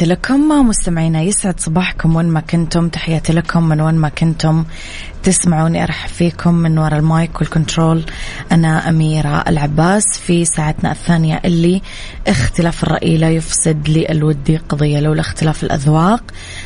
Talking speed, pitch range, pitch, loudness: 130 wpm, 155-170 Hz, 165 Hz, -14 LUFS